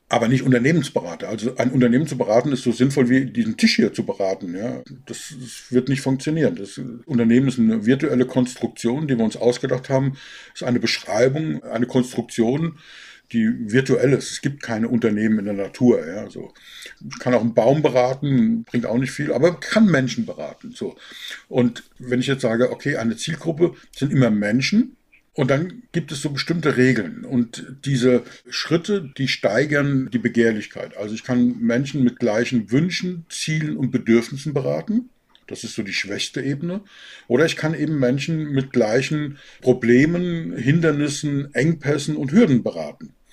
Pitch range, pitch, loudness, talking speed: 120-155 Hz, 130 Hz, -20 LUFS, 170 wpm